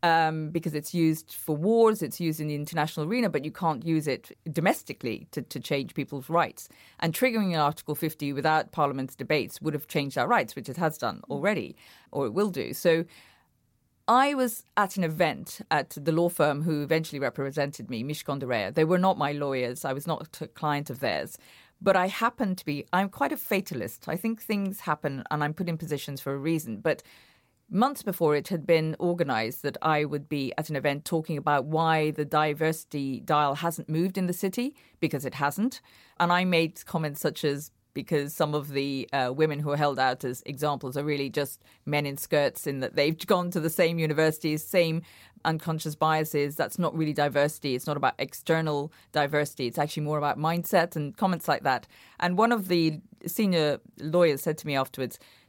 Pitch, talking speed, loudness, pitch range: 155 Hz, 200 wpm, -28 LUFS, 145-170 Hz